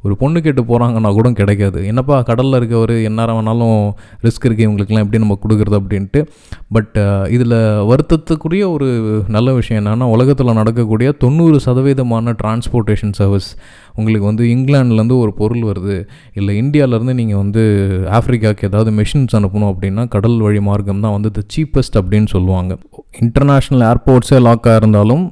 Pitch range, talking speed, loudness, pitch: 105-125 Hz, 140 wpm, -13 LUFS, 110 Hz